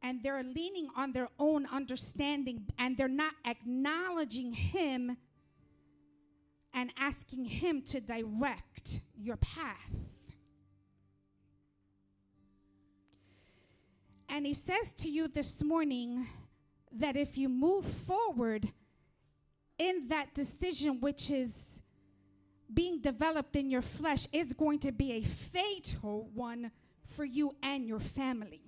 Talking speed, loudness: 110 wpm, -36 LUFS